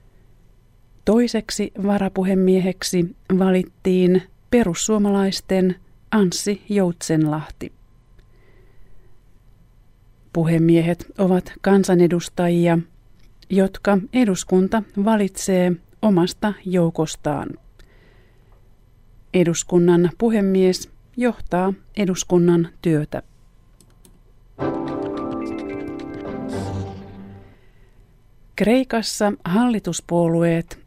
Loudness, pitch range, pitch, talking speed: -20 LUFS, 120-195 Hz, 175 Hz, 40 wpm